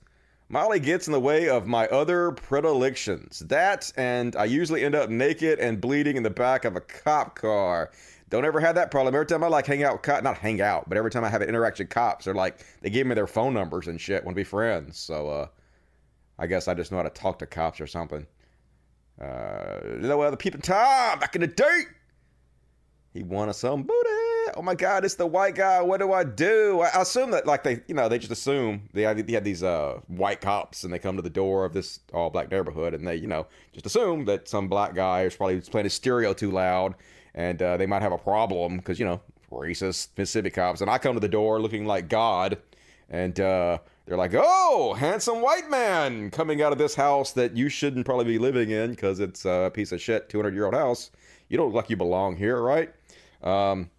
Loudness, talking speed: -25 LUFS, 230 wpm